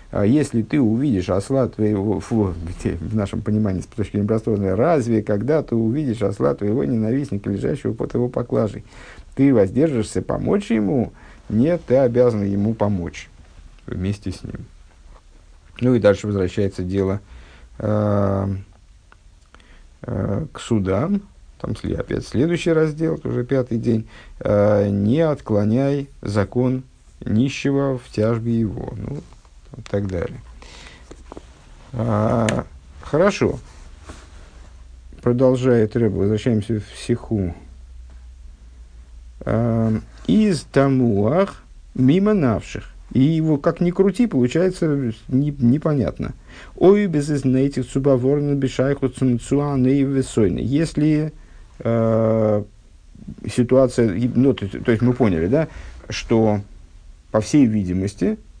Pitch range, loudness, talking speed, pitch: 95-130 Hz, -20 LUFS, 105 wpm, 110 Hz